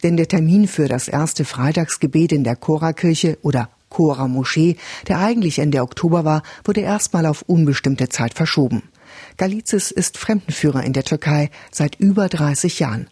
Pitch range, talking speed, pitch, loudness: 140-180 Hz, 150 wpm, 160 Hz, -18 LUFS